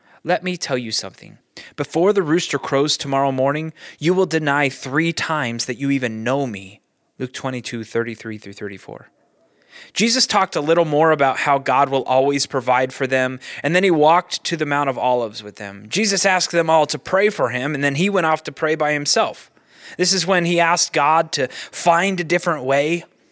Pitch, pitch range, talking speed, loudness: 145 Hz, 130-170 Hz, 200 wpm, -18 LUFS